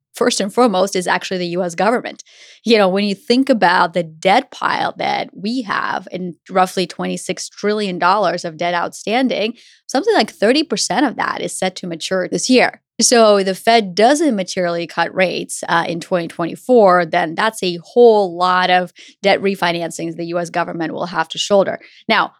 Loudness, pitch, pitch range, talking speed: -16 LUFS, 185 Hz, 175-215 Hz, 175 wpm